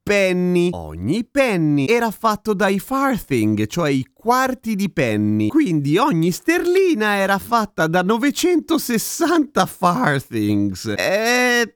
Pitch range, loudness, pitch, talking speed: 155-245 Hz, -18 LUFS, 200 Hz, 105 wpm